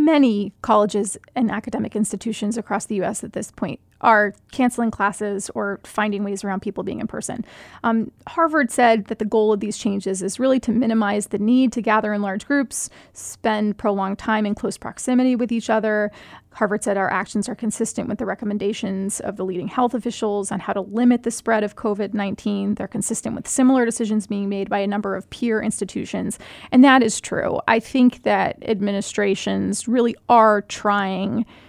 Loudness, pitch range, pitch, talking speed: -21 LUFS, 200-230 Hz, 215 Hz, 185 wpm